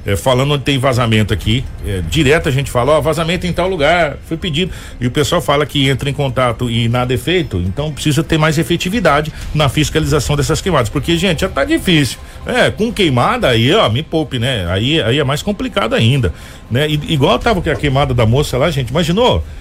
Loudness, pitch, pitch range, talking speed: -14 LUFS, 145 Hz, 125-160 Hz, 215 wpm